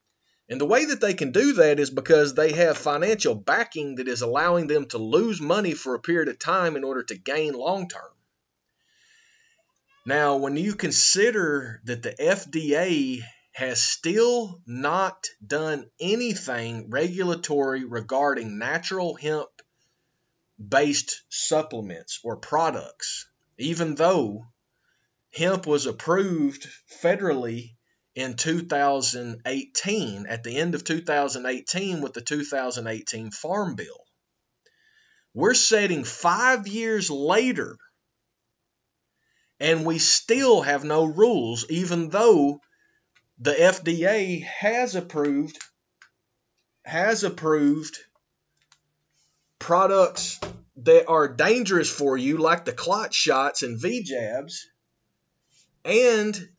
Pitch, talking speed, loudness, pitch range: 155 Hz, 110 wpm, -23 LUFS, 135-190 Hz